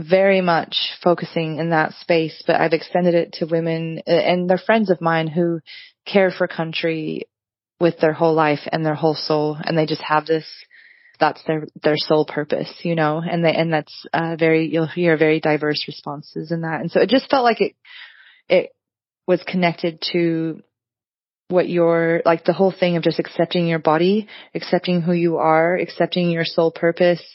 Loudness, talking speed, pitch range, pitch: -19 LUFS, 185 wpm, 160-180 Hz, 165 Hz